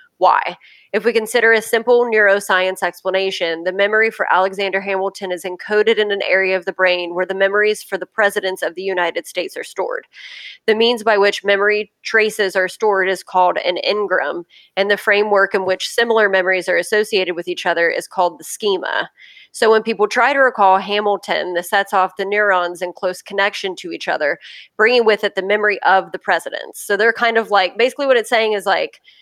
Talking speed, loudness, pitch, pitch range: 200 wpm, -16 LUFS, 200 Hz, 185-220 Hz